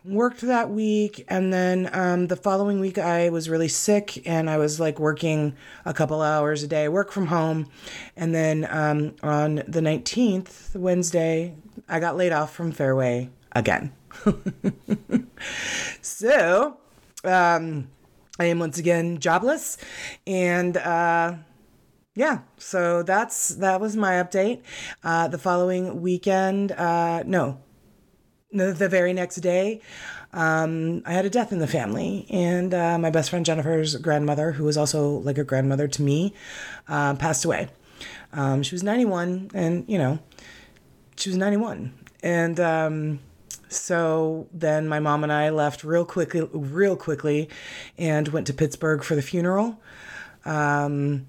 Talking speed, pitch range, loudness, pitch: 145 wpm, 155-185 Hz, -24 LUFS, 170 Hz